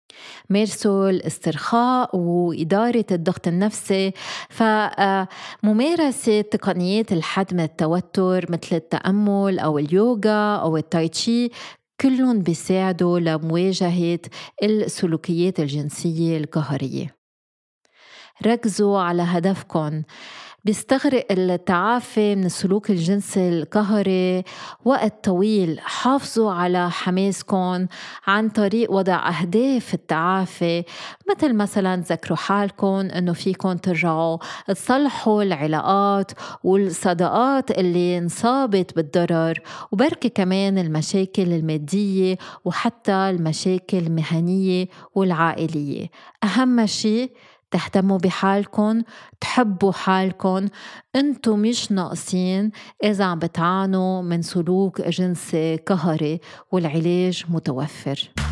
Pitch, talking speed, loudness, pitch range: 190 Hz, 80 wpm, -21 LUFS, 170-210 Hz